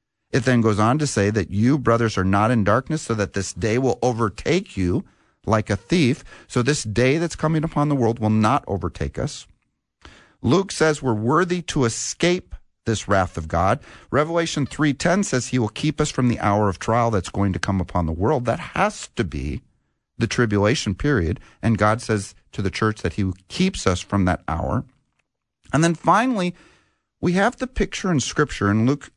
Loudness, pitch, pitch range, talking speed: -21 LUFS, 115 Hz, 100-150 Hz, 195 wpm